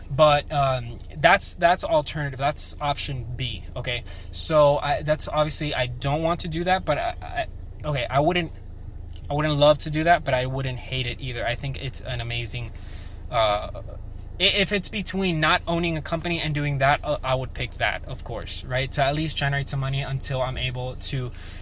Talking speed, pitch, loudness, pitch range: 195 wpm, 135 Hz, -24 LUFS, 120-150 Hz